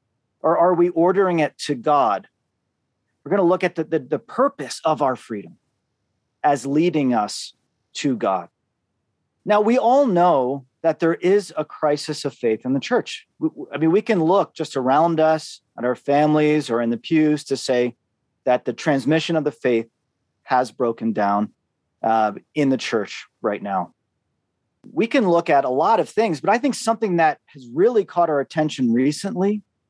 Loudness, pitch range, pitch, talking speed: -20 LUFS, 130-175 Hz, 150 Hz, 180 wpm